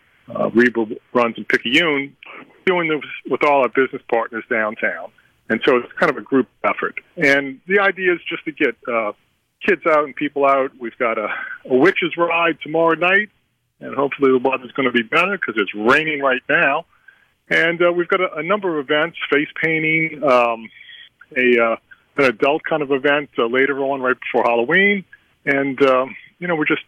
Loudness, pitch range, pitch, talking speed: -18 LUFS, 130-165 Hz, 145 Hz, 190 wpm